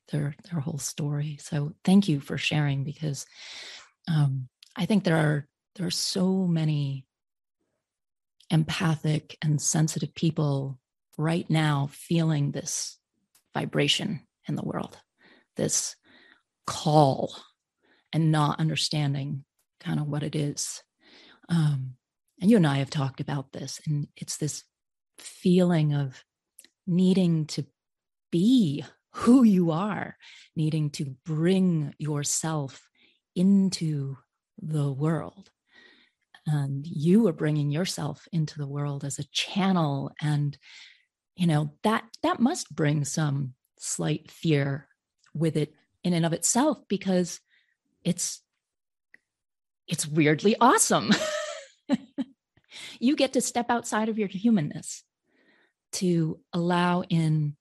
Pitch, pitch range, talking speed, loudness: 160 Hz, 145-190 Hz, 115 wpm, -26 LUFS